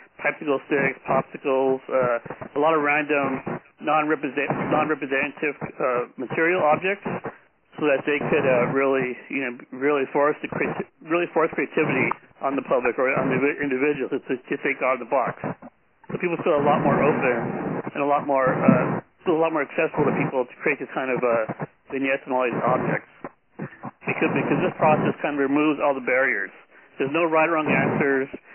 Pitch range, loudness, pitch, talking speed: 135-155 Hz, -23 LUFS, 145 Hz, 185 wpm